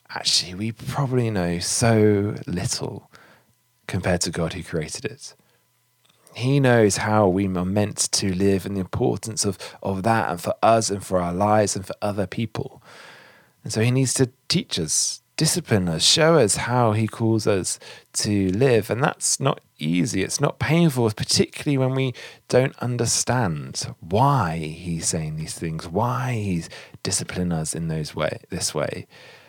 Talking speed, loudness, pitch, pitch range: 160 wpm, -22 LUFS, 110 Hz, 95-125 Hz